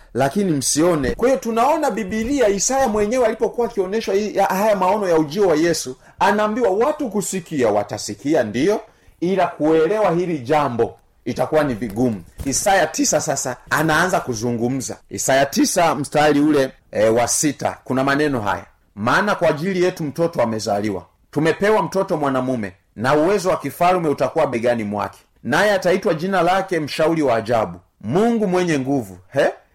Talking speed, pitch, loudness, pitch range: 135 wpm, 155 Hz, -19 LUFS, 125-195 Hz